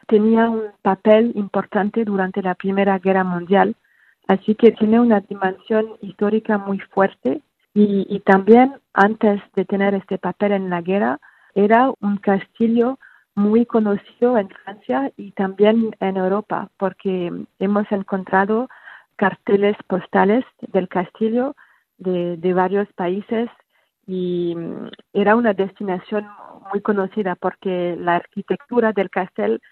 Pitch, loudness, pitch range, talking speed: 200 Hz, -19 LUFS, 190-220 Hz, 125 wpm